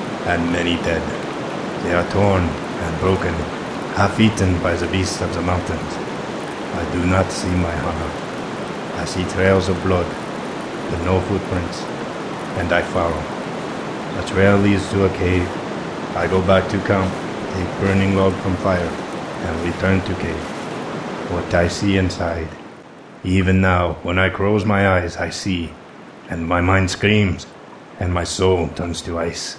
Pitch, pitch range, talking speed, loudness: 90 Hz, 85-95 Hz, 155 wpm, -20 LUFS